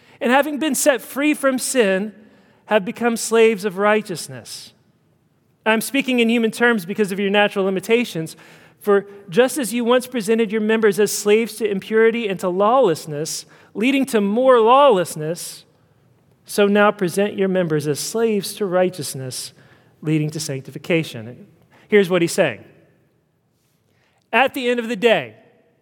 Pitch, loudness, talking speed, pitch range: 205 Hz, -18 LUFS, 145 wpm, 160-230 Hz